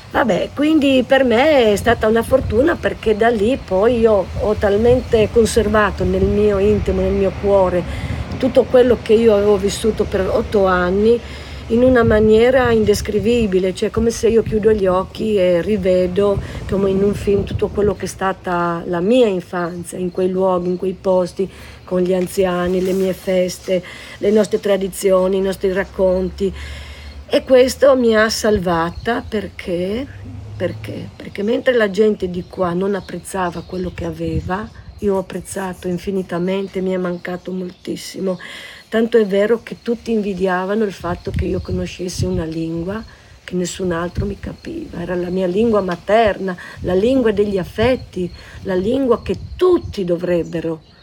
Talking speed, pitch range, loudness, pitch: 155 wpm, 180-220 Hz, -17 LUFS, 195 Hz